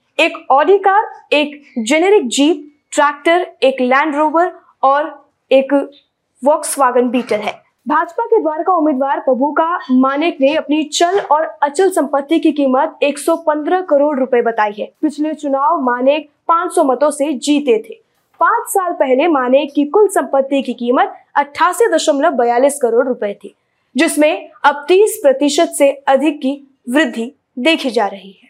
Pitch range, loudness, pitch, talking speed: 270-330 Hz, -14 LUFS, 295 Hz, 140 wpm